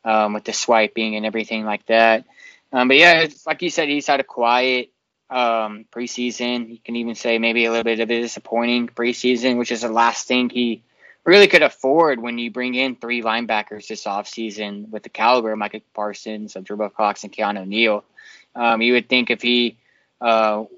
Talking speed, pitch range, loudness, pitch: 200 wpm, 110-125 Hz, -18 LUFS, 115 Hz